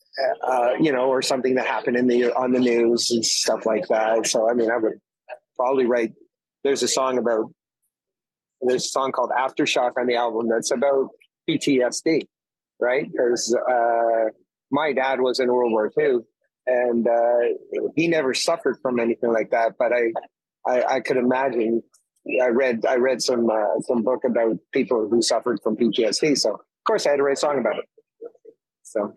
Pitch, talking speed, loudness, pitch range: 125 Hz, 185 wpm, -22 LUFS, 115-135 Hz